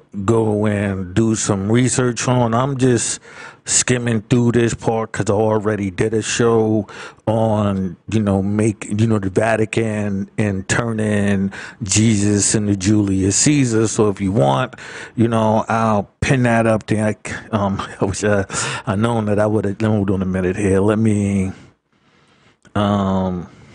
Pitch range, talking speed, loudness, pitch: 100-115 Hz, 155 wpm, -18 LUFS, 110 Hz